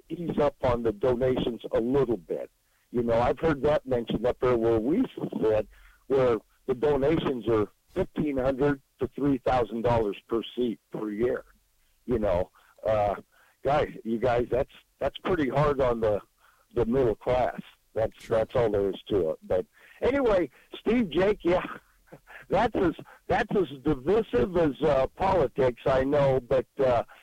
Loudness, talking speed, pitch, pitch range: -27 LUFS, 160 wpm, 130 Hz, 115-155 Hz